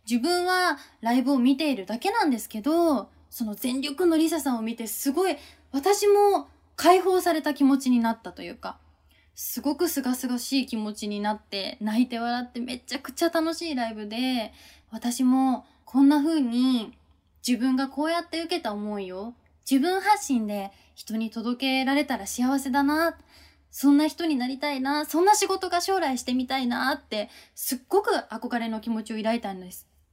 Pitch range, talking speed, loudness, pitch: 230-315 Hz, 335 characters per minute, -25 LUFS, 260 Hz